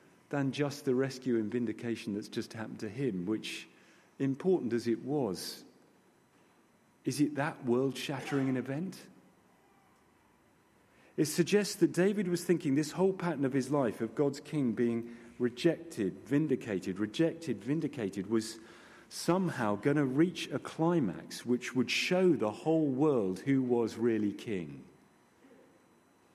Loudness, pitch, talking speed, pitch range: -33 LUFS, 135 Hz, 135 wpm, 115-155 Hz